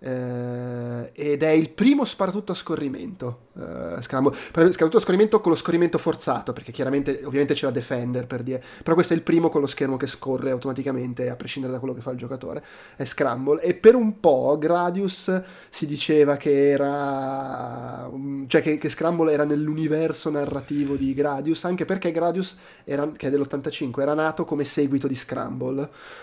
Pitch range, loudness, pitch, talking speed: 135-165 Hz, -23 LUFS, 145 Hz, 170 wpm